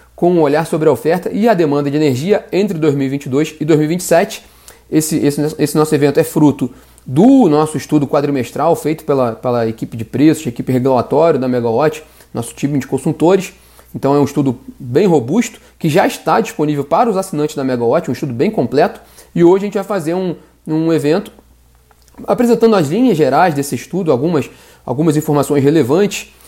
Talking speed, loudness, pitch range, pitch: 175 wpm, -14 LUFS, 140-175 Hz, 150 Hz